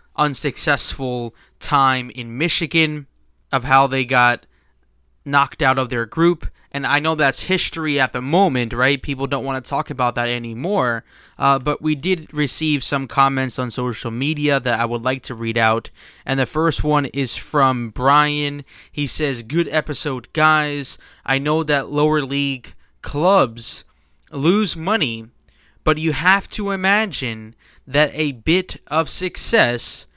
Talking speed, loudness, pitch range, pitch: 155 wpm, -19 LUFS, 125-155 Hz, 140 Hz